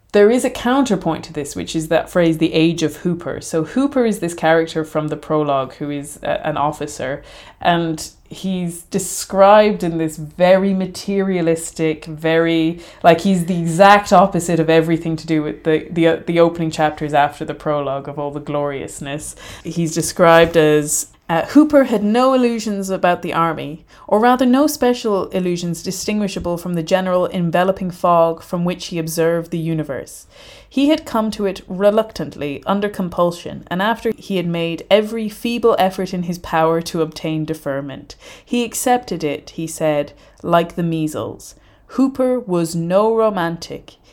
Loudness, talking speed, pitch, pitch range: -17 LUFS, 160 wpm, 170 Hz, 160-195 Hz